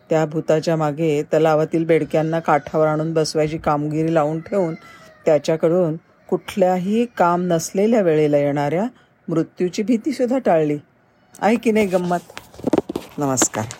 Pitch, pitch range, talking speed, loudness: 165 Hz, 155-185 Hz, 105 wpm, -19 LUFS